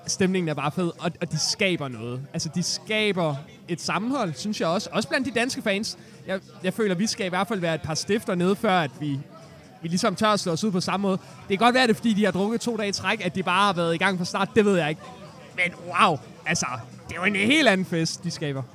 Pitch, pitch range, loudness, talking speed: 185 Hz, 165-210 Hz, -24 LUFS, 275 wpm